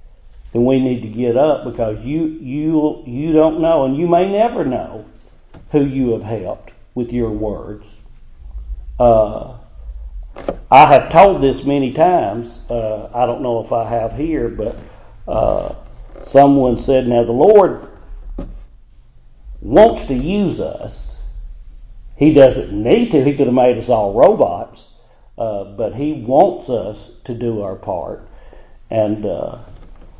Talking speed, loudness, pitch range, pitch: 145 wpm, -15 LUFS, 110-140 Hz, 120 Hz